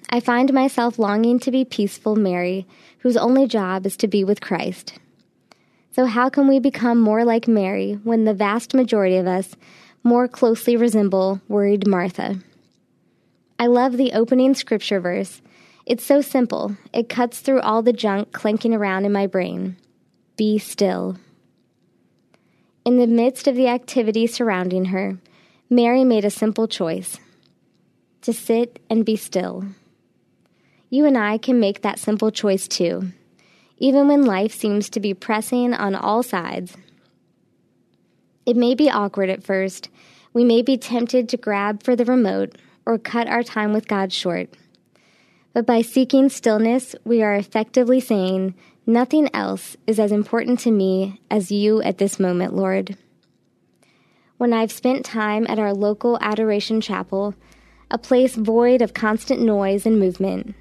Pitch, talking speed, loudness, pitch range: 220 Hz, 150 wpm, -19 LUFS, 200-245 Hz